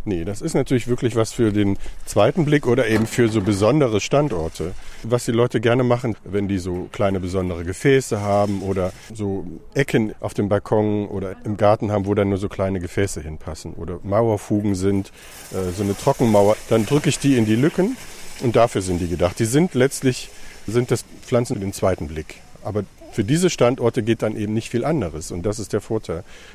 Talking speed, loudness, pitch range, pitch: 195 wpm, -21 LUFS, 100-120 Hz, 105 Hz